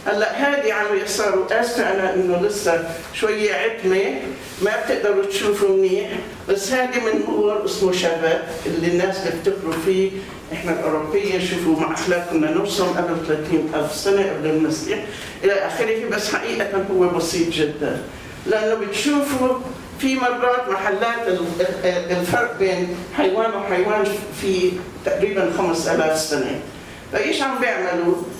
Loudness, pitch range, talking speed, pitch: -20 LUFS, 170-210 Hz, 125 wpm, 190 Hz